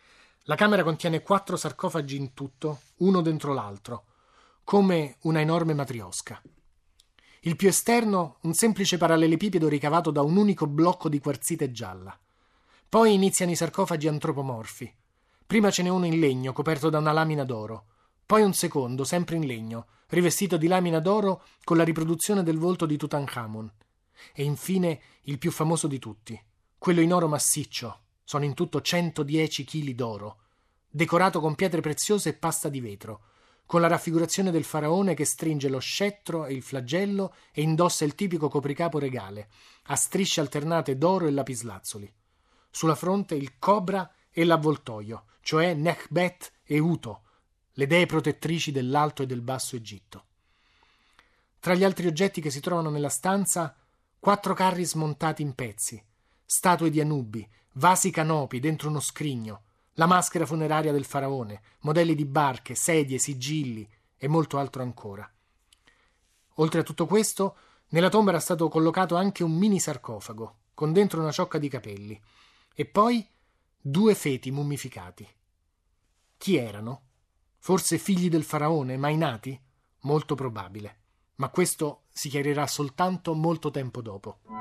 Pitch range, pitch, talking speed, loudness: 125-170 Hz, 150 Hz, 145 wpm, -26 LUFS